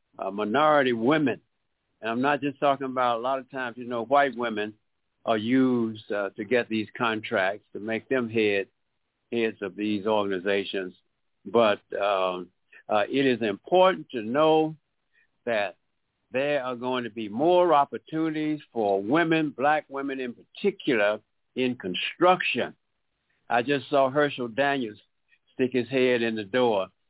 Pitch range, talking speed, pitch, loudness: 110-140 Hz, 150 wpm, 125 Hz, -26 LUFS